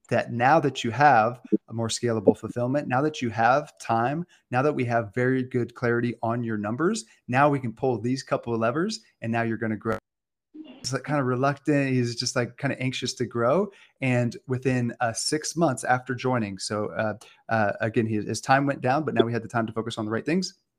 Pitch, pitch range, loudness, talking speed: 125 Hz, 115-140 Hz, -26 LUFS, 225 wpm